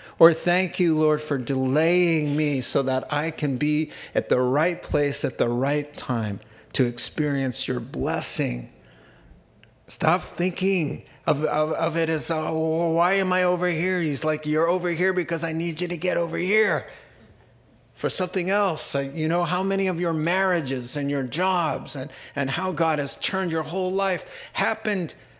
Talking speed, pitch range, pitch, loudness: 170 wpm, 140-180 Hz, 160 Hz, -24 LUFS